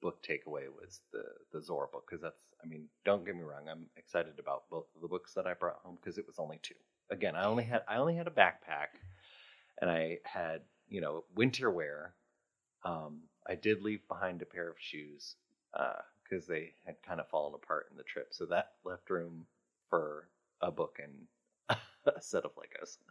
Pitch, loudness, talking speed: 105 Hz, -38 LUFS, 205 wpm